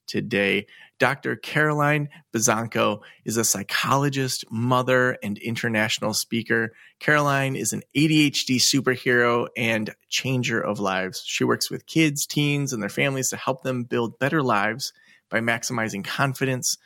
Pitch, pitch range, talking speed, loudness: 125 Hz, 115-140 Hz, 130 wpm, -23 LUFS